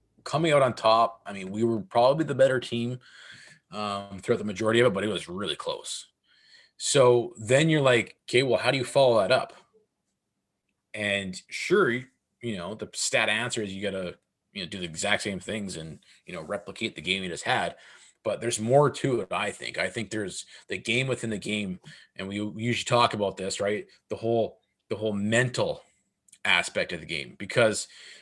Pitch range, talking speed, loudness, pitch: 100-125 Hz, 200 wpm, -26 LUFS, 115 Hz